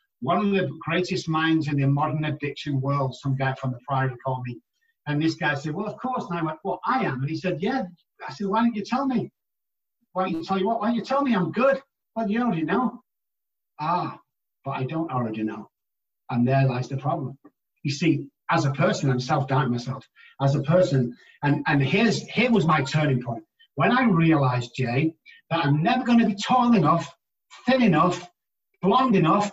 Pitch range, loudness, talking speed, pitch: 140-205 Hz, -24 LUFS, 210 wpm, 165 Hz